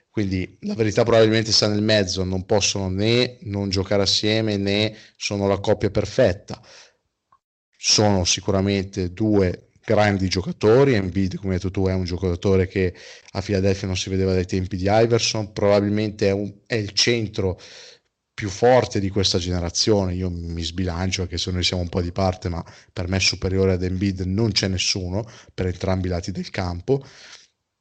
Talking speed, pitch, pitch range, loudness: 170 wpm, 100 Hz, 95-105 Hz, -21 LUFS